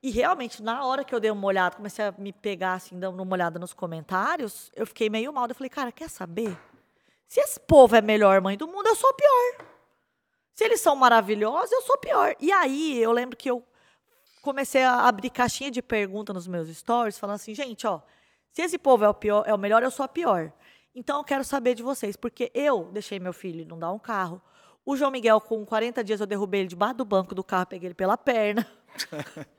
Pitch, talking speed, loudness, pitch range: 225 Hz, 235 wpm, -25 LUFS, 200-260 Hz